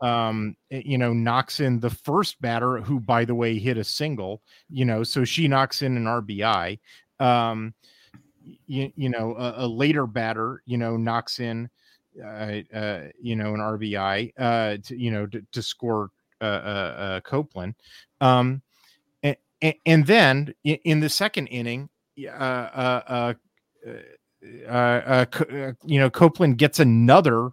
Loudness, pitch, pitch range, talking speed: -23 LUFS, 125 Hz, 115-135 Hz, 155 wpm